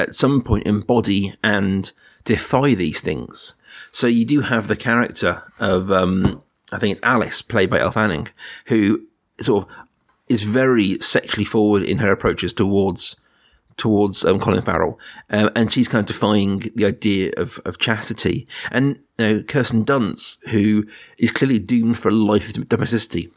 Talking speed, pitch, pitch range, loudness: 165 wpm, 105 Hz, 100-115 Hz, -19 LUFS